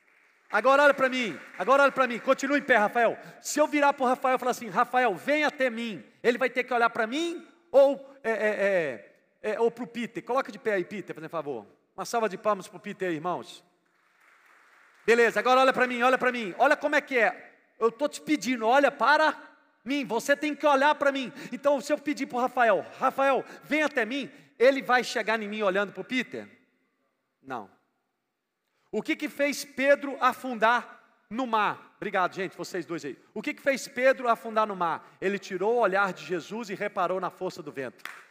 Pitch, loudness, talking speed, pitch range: 245 Hz, -26 LUFS, 210 wpm, 210-275 Hz